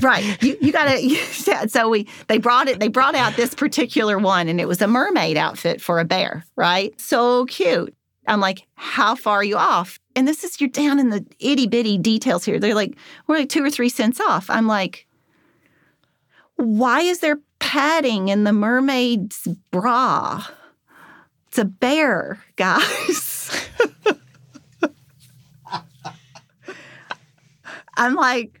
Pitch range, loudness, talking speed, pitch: 200-270 Hz, -19 LUFS, 145 wpm, 235 Hz